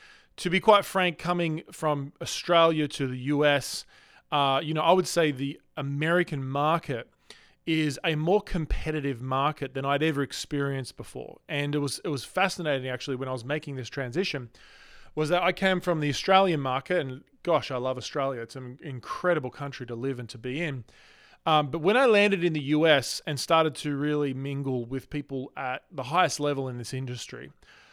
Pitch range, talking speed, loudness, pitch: 135-165 Hz, 185 wpm, -27 LUFS, 145 Hz